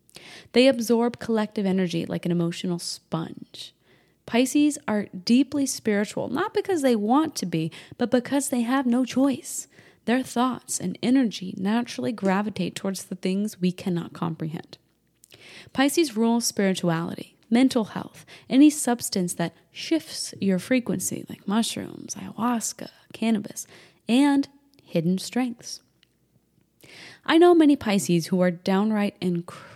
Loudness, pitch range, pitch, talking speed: -24 LUFS, 185-260 Hz, 225 Hz, 125 wpm